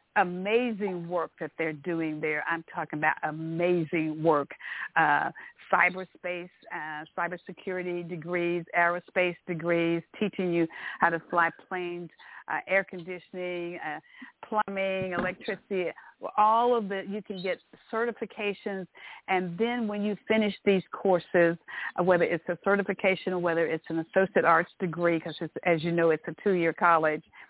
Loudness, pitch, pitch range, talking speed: -28 LUFS, 180 Hz, 170-195 Hz, 140 wpm